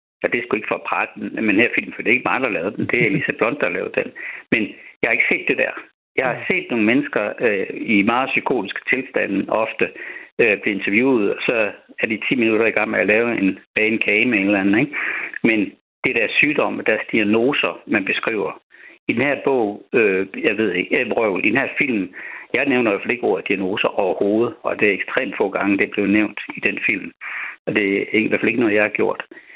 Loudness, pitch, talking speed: -19 LUFS, 110 Hz, 250 wpm